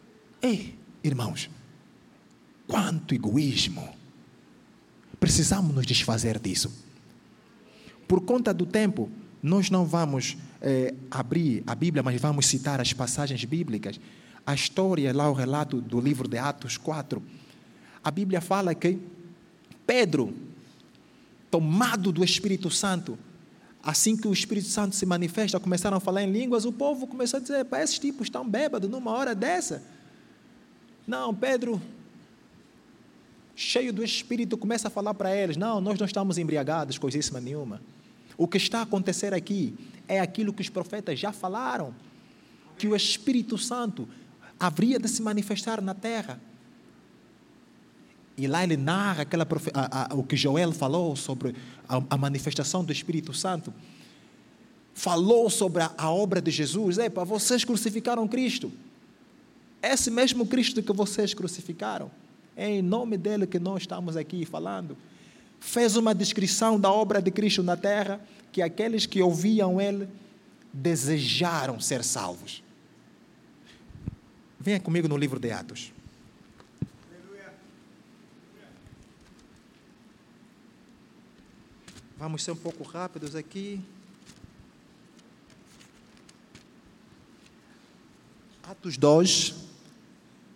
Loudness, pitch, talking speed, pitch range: -27 LUFS, 190 Hz, 120 wpm, 155-215 Hz